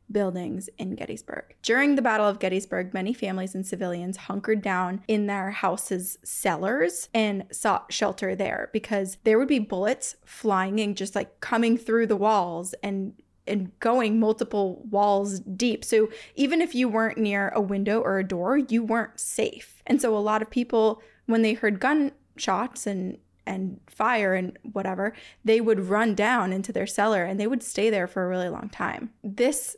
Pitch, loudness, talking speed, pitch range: 210 Hz, -26 LUFS, 175 wpm, 195-230 Hz